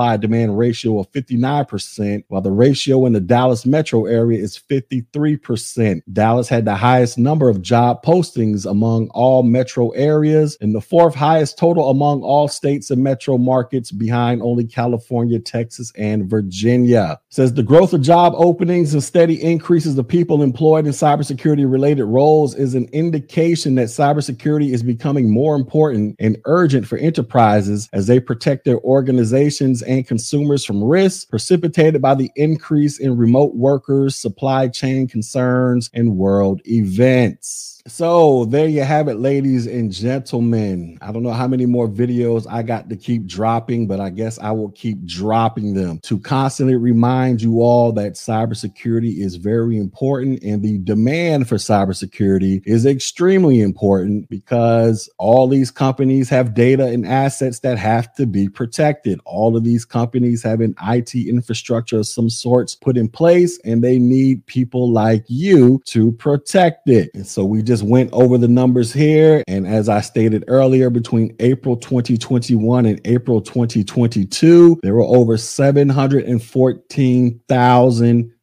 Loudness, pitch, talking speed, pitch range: -15 LUFS, 125 Hz, 155 wpm, 115-135 Hz